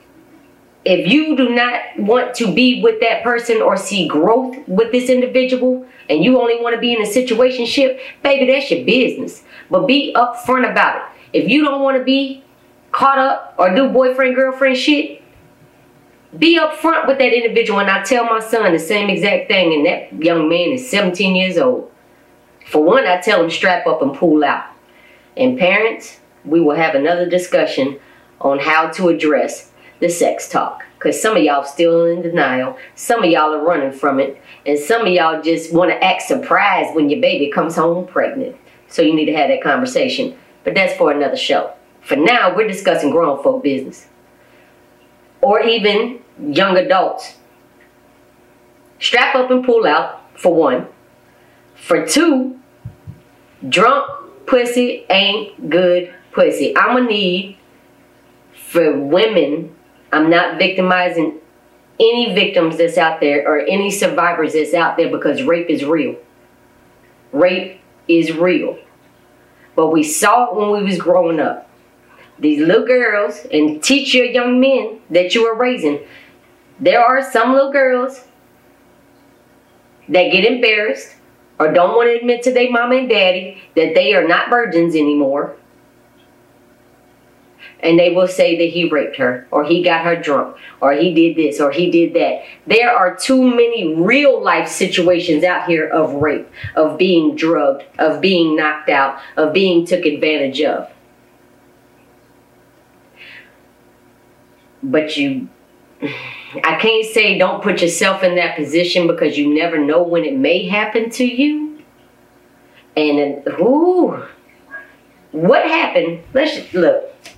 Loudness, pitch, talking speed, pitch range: -14 LUFS, 200 Hz, 155 wpm, 170-255 Hz